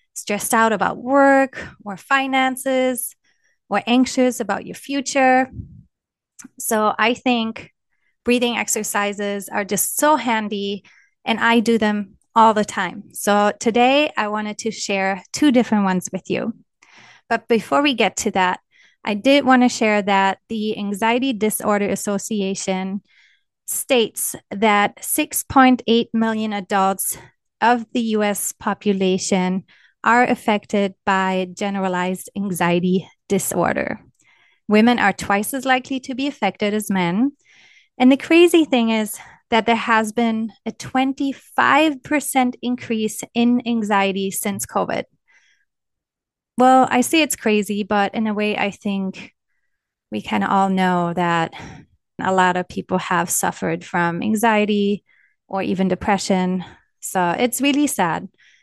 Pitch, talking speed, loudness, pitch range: 215 Hz, 130 wpm, -19 LUFS, 195-250 Hz